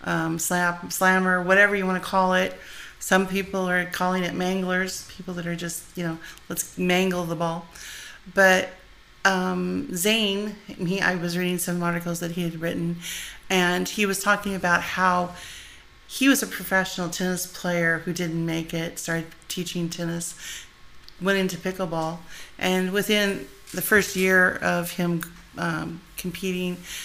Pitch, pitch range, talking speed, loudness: 180 Hz, 170-185 Hz, 155 wpm, -24 LUFS